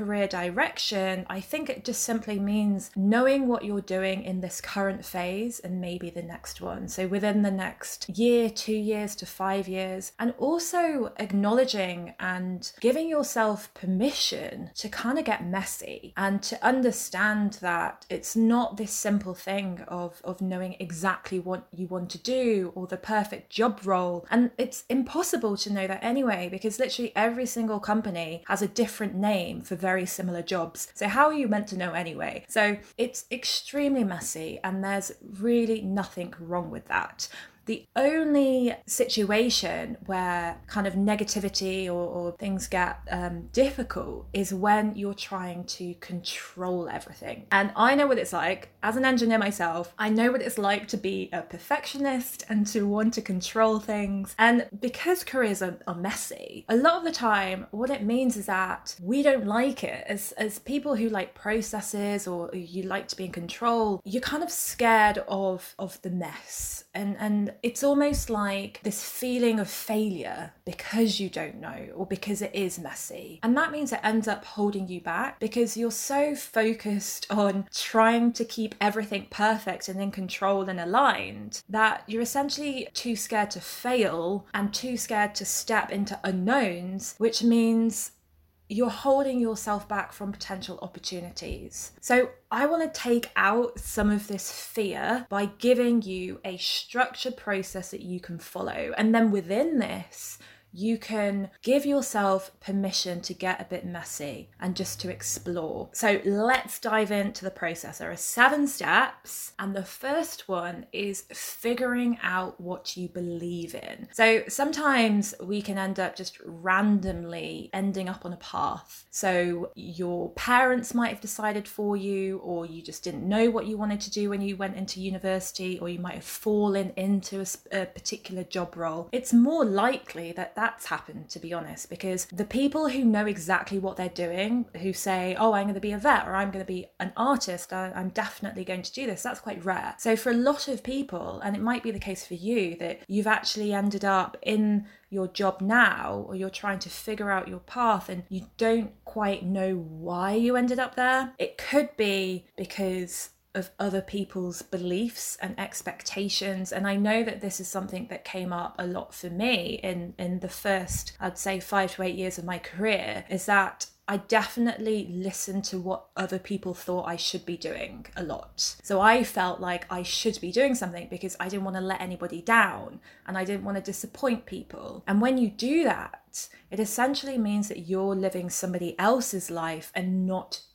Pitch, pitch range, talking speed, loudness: 200 Hz, 185-230 Hz, 180 wpm, -28 LUFS